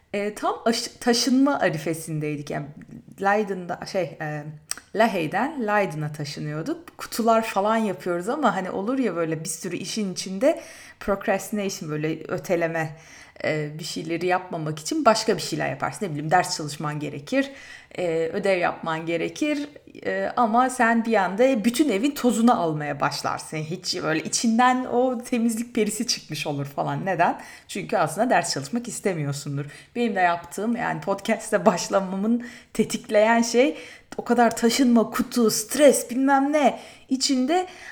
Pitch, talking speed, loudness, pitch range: 210 Hz, 130 wpm, -24 LUFS, 170-240 Hz